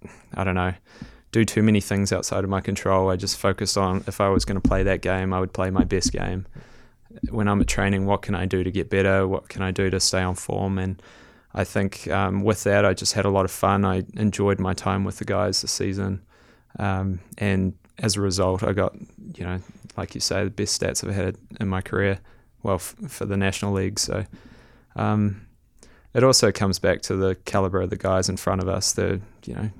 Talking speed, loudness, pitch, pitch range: 230 wpm, -23 LUFS, 95 Hz, 95-100 Hz